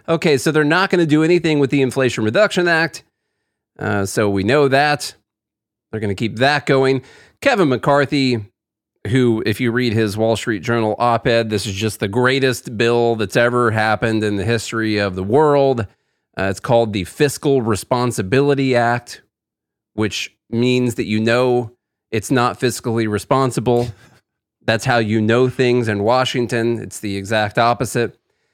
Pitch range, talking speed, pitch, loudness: 110-130 Hz, 165 wpm, 120 Hz, -17 LUFS